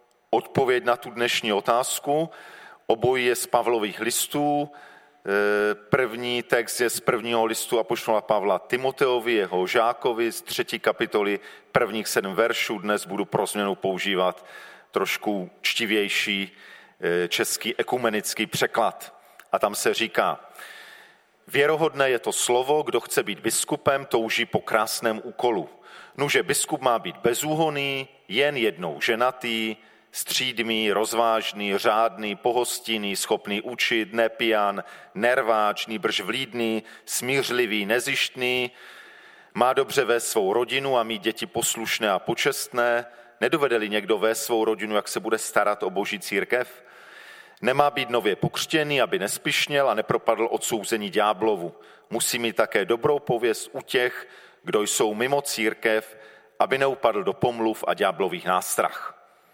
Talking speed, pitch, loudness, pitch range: 125 wpm, 115 Hz, -24 LUFS, 110-125 Hz